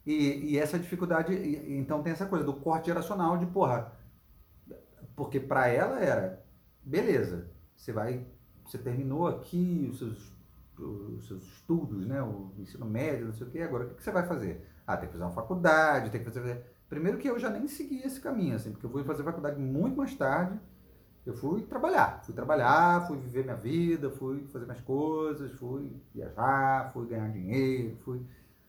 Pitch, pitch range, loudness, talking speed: 135 Hz, 120-165 Hz, -31 LUFS, 180 wpm